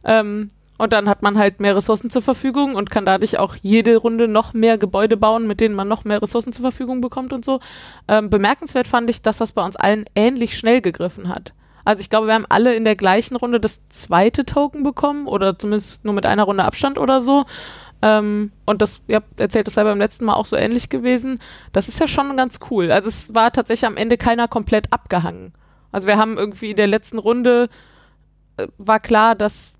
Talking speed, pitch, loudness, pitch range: 220 wpm, 220 Hz, -17 LUFS, 210-240 Hz